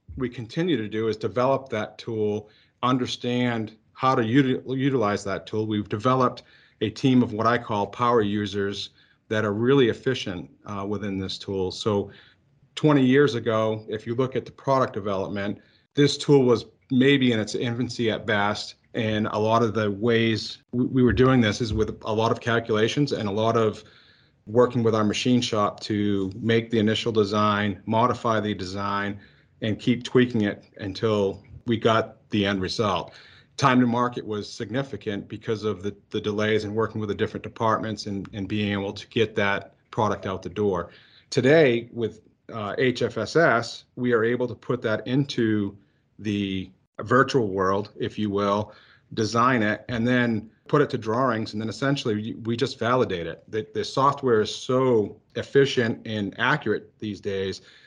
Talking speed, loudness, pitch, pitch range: 170 wpm, -24 LUFS, 110 Hz, 105-125 Hz